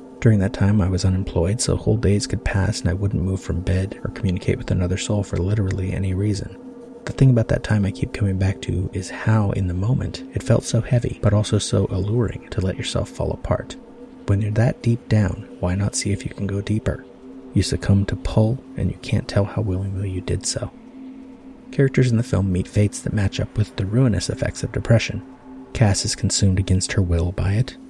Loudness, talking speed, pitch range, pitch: -21 LUFS, 220 wpm, 95-120 Hz, 105 Hz